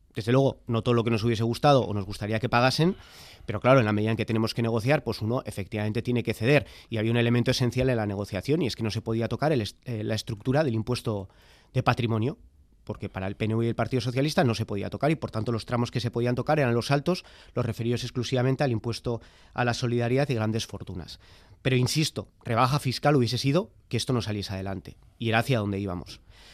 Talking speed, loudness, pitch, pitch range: 235 wpm, -27 LUFS, 115 Hz, 105-125 Hz